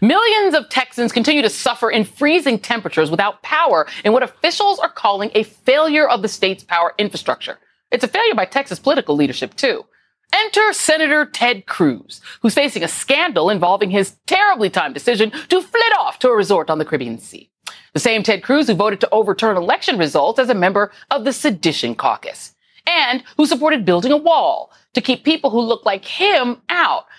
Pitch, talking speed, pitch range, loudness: 245 Hz, 190 wpm, 205-310 Hz, -16 LUFS